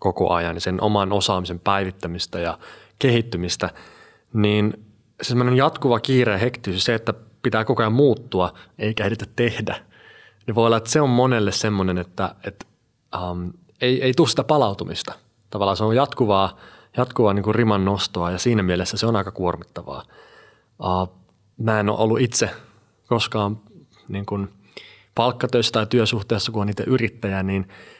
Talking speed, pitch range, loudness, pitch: 155 wpm, 95-115 Hz, -21 LUFS, 105 Hz